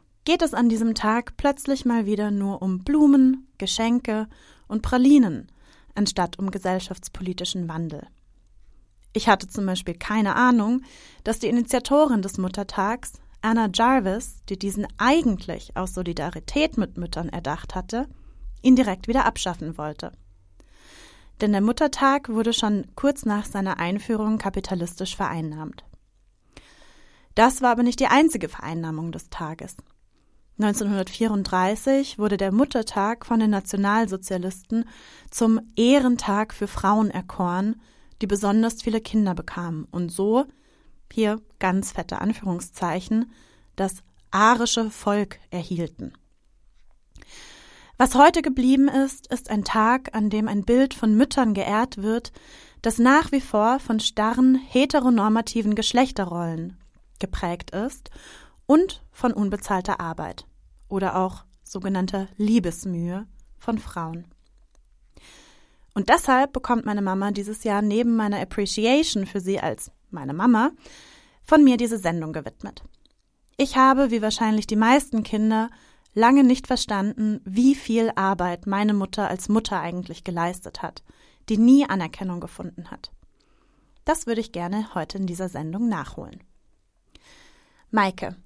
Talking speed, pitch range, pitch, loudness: 125 wpm, 185-240 Hz, 210 Hz, -23 LUFS